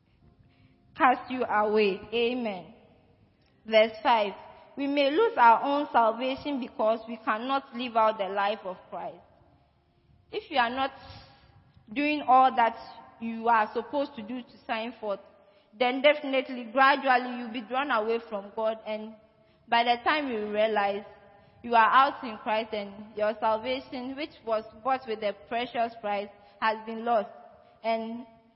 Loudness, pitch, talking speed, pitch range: -27 LUFS, 230 Hz, 145 wpm, 215-260 Hz